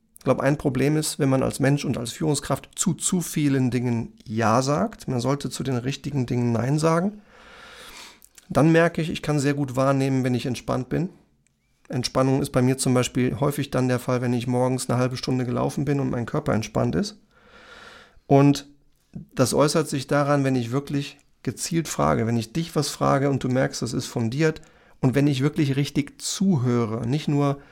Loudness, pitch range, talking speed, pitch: -23 LUFS, 125-150 Hz, 195 wpm, 140 Hz